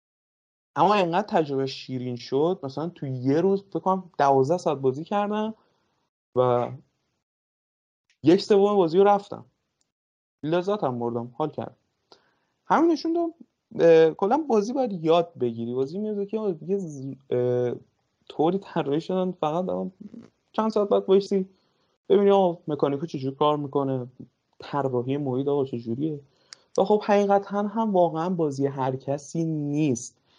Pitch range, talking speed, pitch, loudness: 135-200 Hz, 135 wpm, 165 Hz, -24 LUFS